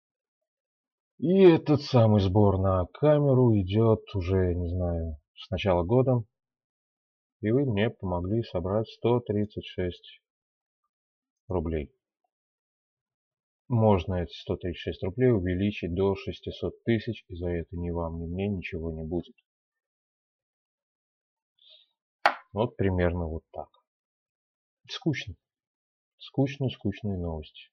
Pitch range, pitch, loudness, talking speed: 90-130 Hz, 105 Hz, -27 LUFS, 105 wpm